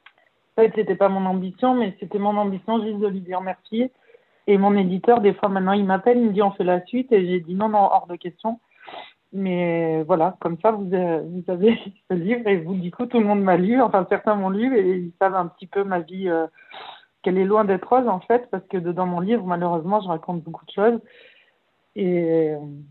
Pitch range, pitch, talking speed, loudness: 180-220 Hz, 195 Hz, 235 wpm, -21 LUFS